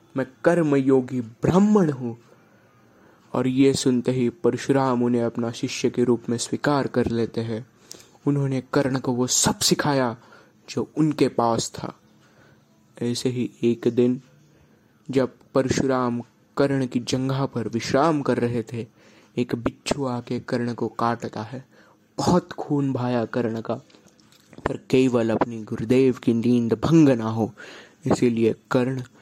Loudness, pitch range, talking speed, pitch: -23 LUFS, 115-135 Hz, 135 wpm, 125 Hz